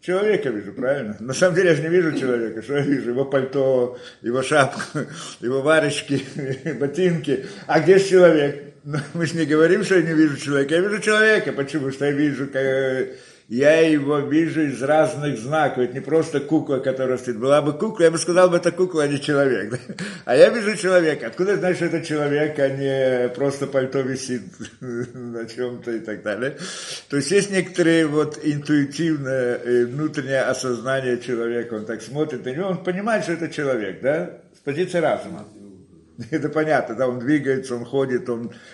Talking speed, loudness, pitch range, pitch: 180 wpm, -21 LUFS, 130-160 Hz, 145 Hz